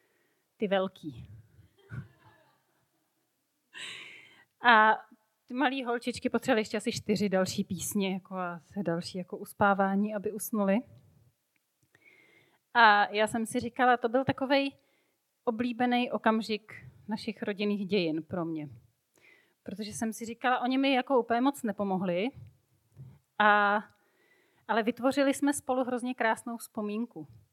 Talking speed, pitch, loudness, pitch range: 115 wpm, 215 Hz, -29 LUFS, 190-245 Hz